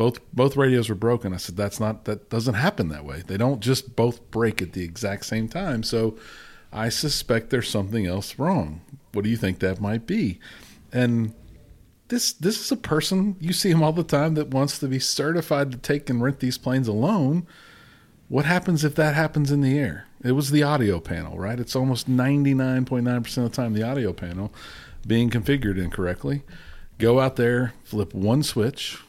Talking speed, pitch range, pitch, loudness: 195 wpm, 105-140 Hz, 120 Hz, -24 LUFS